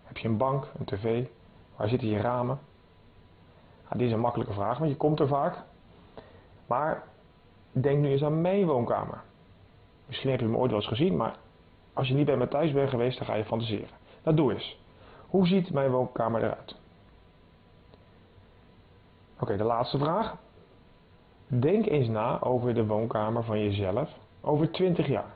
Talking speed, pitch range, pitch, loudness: 175 wpm, 100-135 Hz, 115 Hz, -28 LUFS